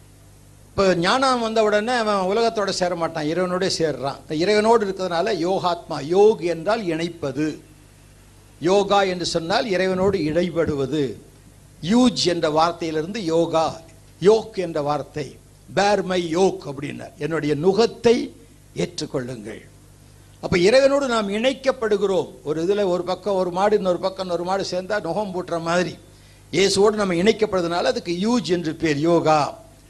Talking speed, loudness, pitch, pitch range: 120 wpm, -21 LUFS, 175 Hz, 150-200 Hz